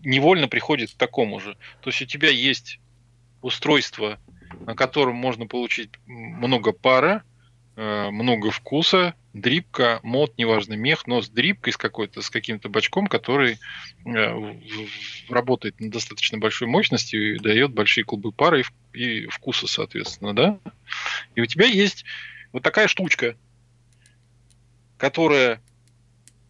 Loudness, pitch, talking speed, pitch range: -21 LUFS, 120 Hz, 130 wpm, 115-125 Hz